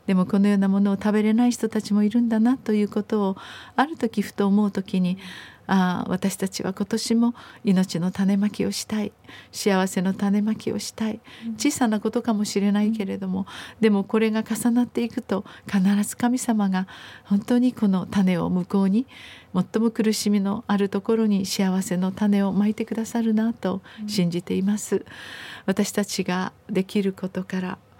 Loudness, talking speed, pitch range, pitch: -23 LUFS, 330 characters per minute, 195-225 Hz, 205 Hz